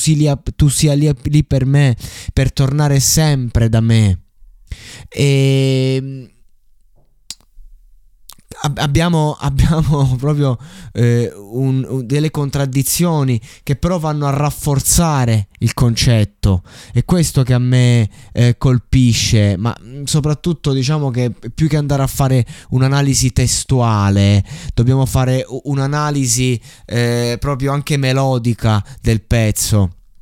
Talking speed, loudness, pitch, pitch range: 105 wpm, -15 LUFS, 130 Hz, 120-145 Hz